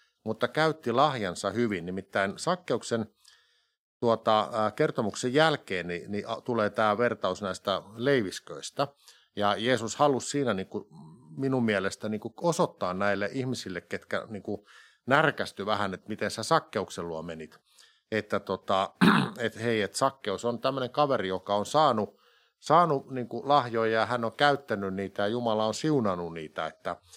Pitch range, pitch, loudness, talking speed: 100-130 Hz, 110 Hz, -28 LUFS, 145 wpm